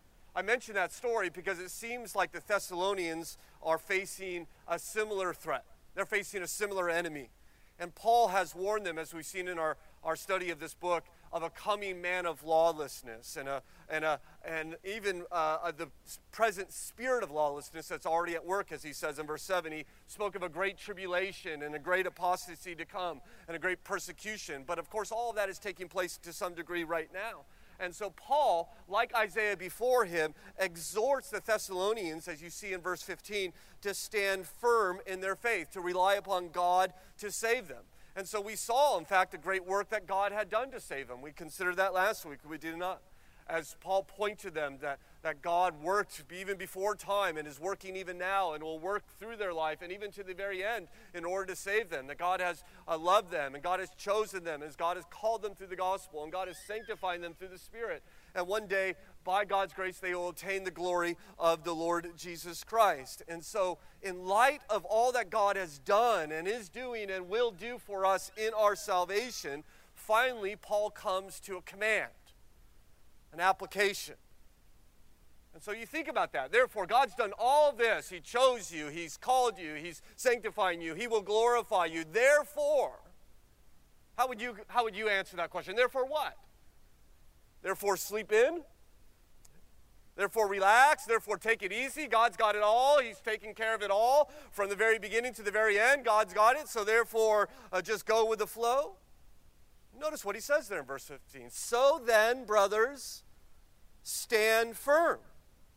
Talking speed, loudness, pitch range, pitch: 190 wpm, -33 LUFS, 175-220 Hz, 190 Hz